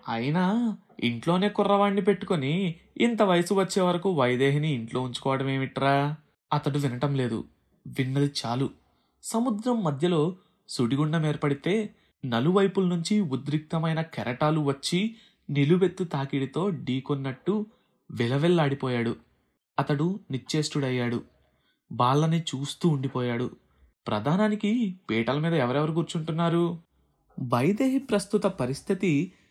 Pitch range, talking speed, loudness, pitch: 135-190 Hz, 85 wpm, -27 LUFS, 155 Hz